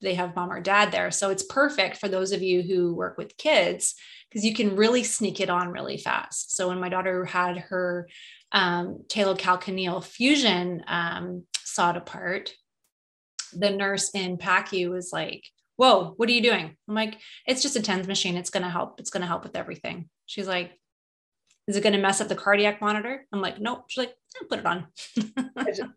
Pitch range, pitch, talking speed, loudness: 180-220 Hz, 195 Hz, 190 wpm, -25 LUFS